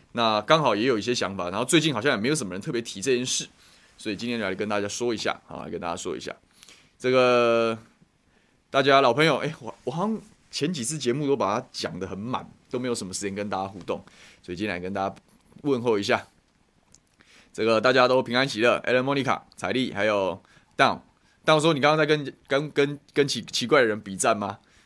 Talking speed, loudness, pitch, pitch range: 330 characters per minute, -25 LUFS, 125 Hz, 105-145 Hz